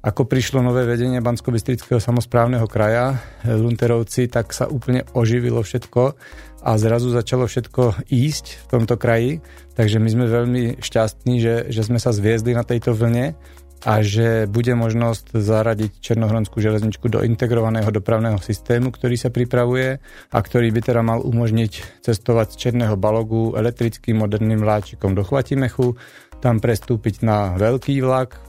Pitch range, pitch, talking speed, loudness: 110-125 Hz, 115 Hz, 145 wpm, -19 LUFS